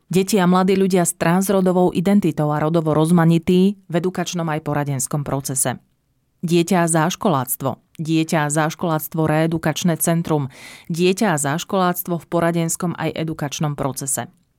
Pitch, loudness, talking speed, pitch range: 165 Hz, -19 LUFS, 130 wpm, 150-180 Hz